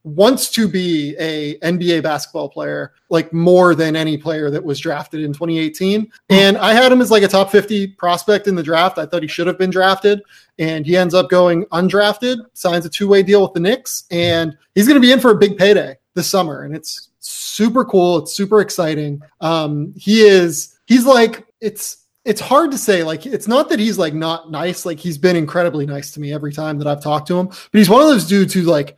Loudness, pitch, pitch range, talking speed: -15 LUFS, 180 Hz, 160-205 Hz, 225 wpm